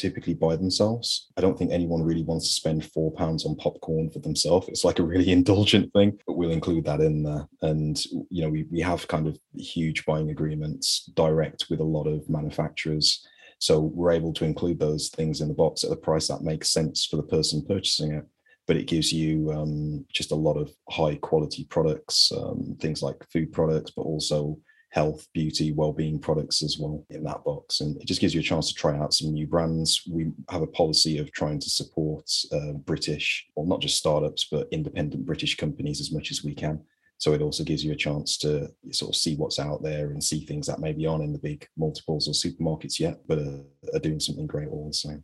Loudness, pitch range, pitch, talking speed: -26 LUFS, 75-80 Hz, 80 Hz, 220 wpm